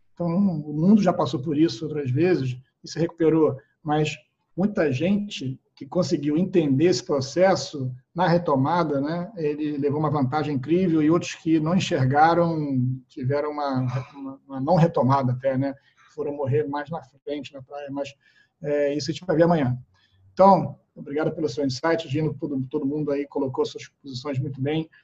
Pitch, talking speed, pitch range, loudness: 150 Hz, 175 wpm, 140-165 Hz, -24 LUFS